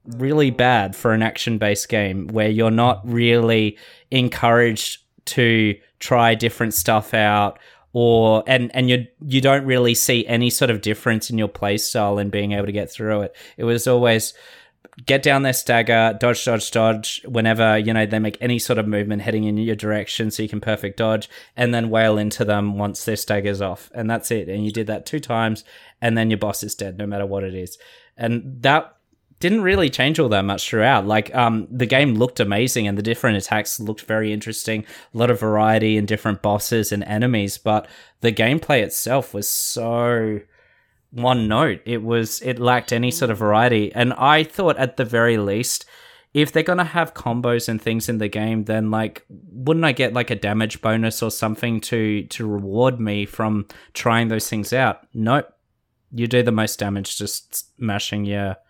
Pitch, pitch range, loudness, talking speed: 110 Hz, 105-120 Hz, -20 LUFS, 195 wpm